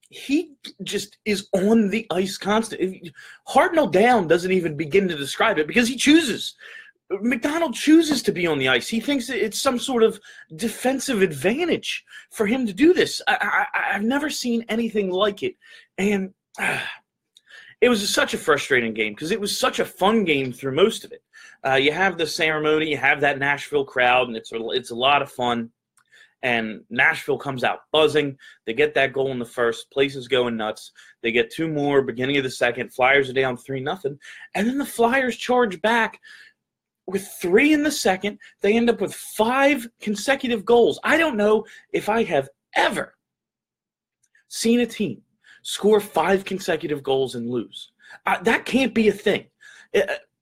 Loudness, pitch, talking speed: -21 LUFS, 210 Hz, 180 wpm